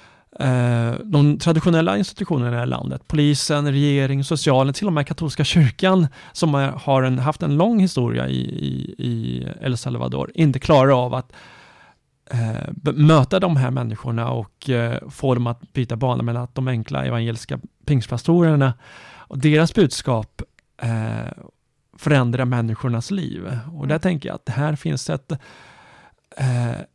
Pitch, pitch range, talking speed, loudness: 135 Hz, 120-155 Hz, 145 wpm, -20 LUFS